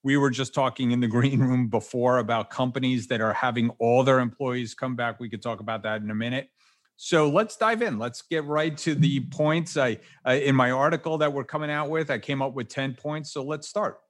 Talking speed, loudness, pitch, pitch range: 240 wpm, -25 LUFS, 130 Hz, 120-150 Hz